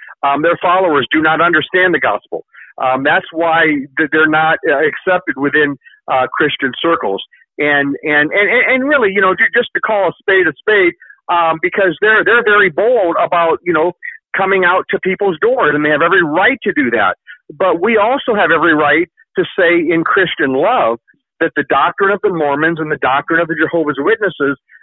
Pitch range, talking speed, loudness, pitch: 155-215 Hz, 190 wpm, -13 LUFS, 175 Hz